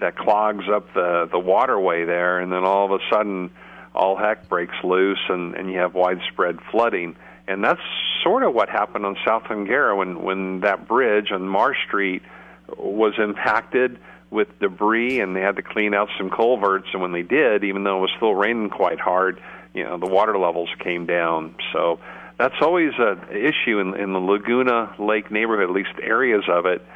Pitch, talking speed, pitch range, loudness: 100 Hz, 190 wpm, 90-105 Hz, -21 LUFS